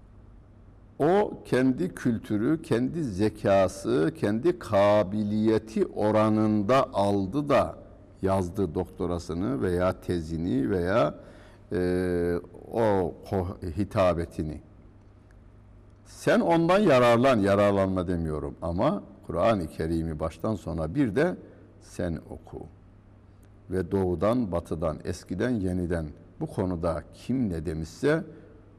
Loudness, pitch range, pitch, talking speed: -27 LUFS, 90-105 Hz, 100 Hz, 90 wpm